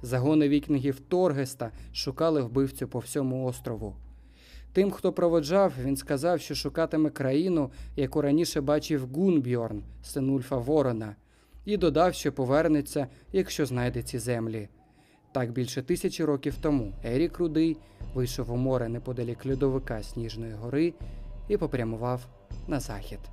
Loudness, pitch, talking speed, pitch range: -28 LUFS, 135 Hz, 125 wpm, 120-155 Hz